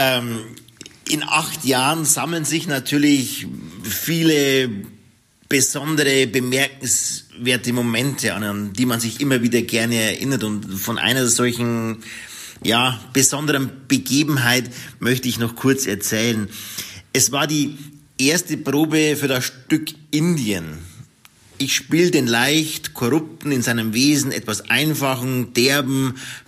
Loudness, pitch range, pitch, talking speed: -19 LUFS, 115-145 Hz, 130 Hz, 115 wpm